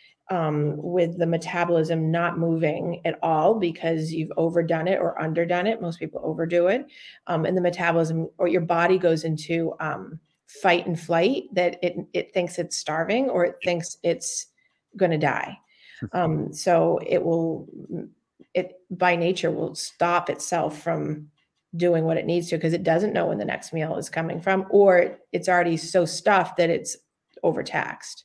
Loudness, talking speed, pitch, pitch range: -24 LUFS, 170 wpm, 170 Hz, 165-180 Hz